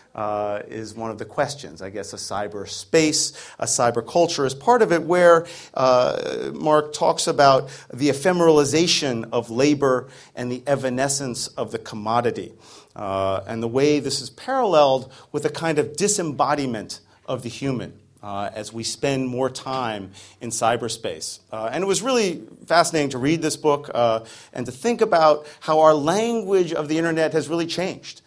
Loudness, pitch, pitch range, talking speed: -21 LUFS, 140 Hz, 115-160 Hz, 165 wpm